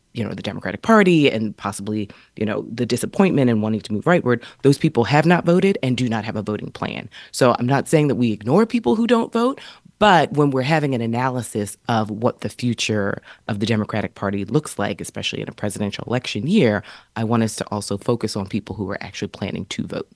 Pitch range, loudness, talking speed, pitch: 105-150 Hz, -20 LUFS, 225 wpm, 120 Hz